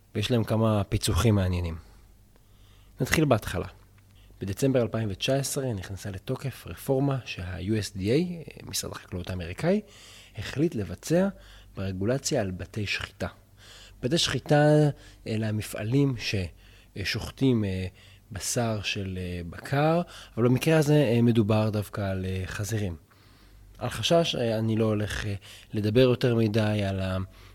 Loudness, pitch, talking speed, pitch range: -27 LUFS, 105 Hz, 100 wpm, 95-125 Hz